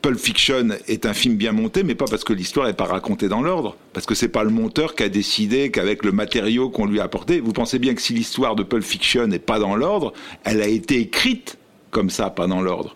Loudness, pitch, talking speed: -20 LUFS, 125 Hz, 260 wpm